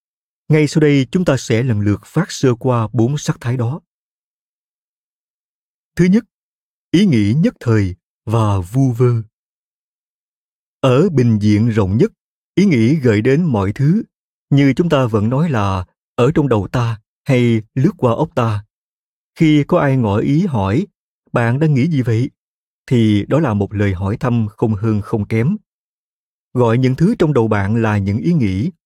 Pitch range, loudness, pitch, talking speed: 110-150 Hz, -16 LUFS, 120 Hz, 170 wpm